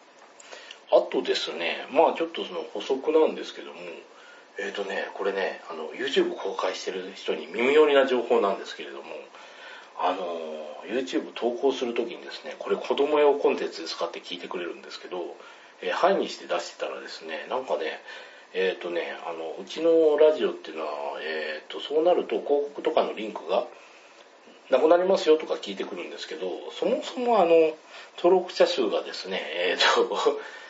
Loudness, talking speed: -26 LUFS, 385 characters per minute